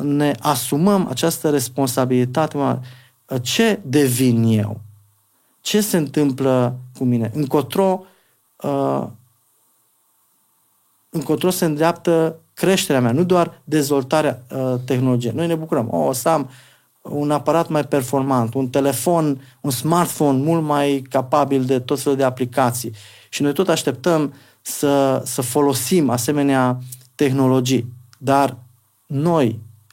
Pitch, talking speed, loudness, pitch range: 140 Hz, 110 wpm, -19 LUFS, 125-155 Hz